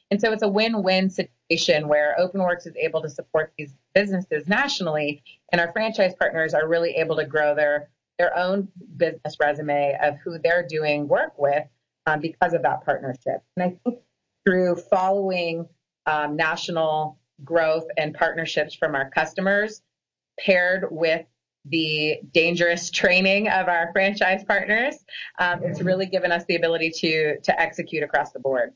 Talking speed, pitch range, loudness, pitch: 155 wpm, 155-185 Hz, -22 LUFS, 170 Hz